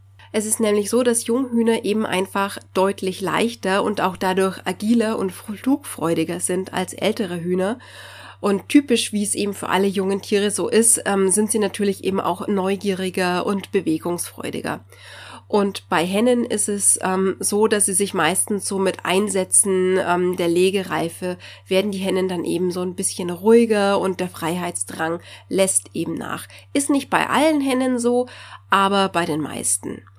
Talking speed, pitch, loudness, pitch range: 155 wpm, 195 Hz, -20 LUFS, 180-210 Hz